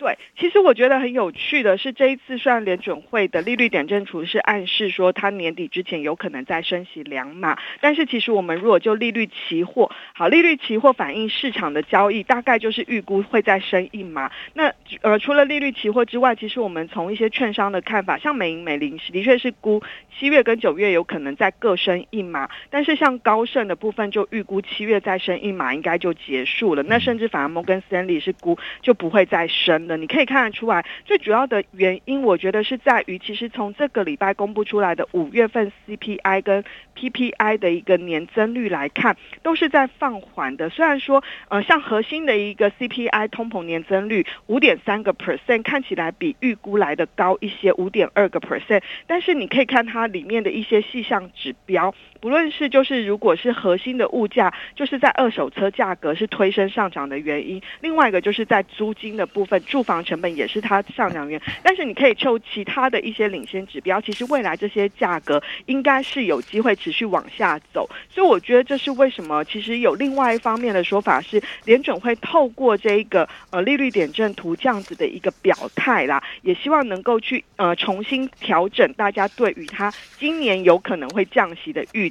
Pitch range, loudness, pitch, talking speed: 190-255 Hz, -20 LUFS, 215 Hz, 320 characters per minute